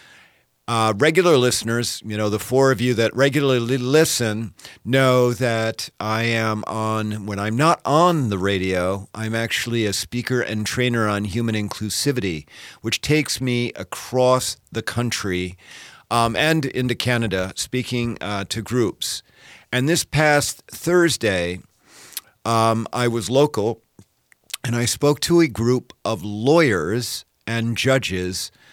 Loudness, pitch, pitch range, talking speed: -20 LUFS, 115 Hz, 105-130 Hz, 135 wpm